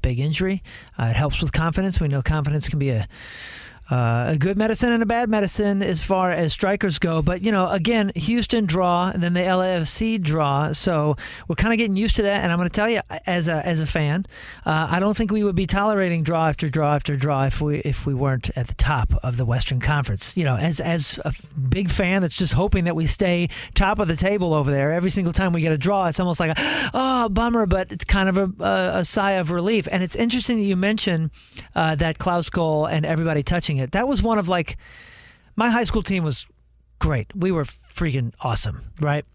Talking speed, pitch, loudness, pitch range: 235 wpm, 170 Hz, -21 LUFS, 150-195 Hz